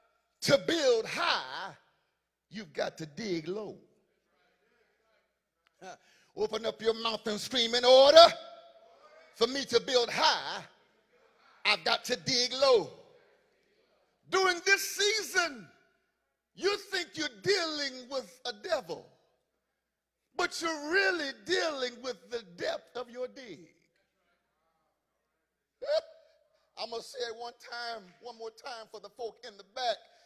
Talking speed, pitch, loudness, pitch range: 125 wpm, 275 Hz, -29 LUFS, 235-350 Hz